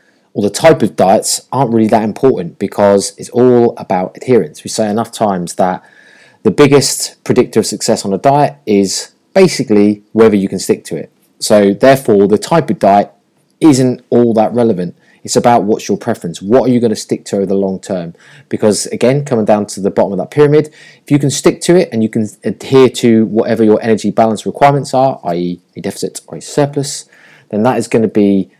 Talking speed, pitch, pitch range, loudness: 210 wpm, 115 Hz, 100-135 Hz, -12 LUFS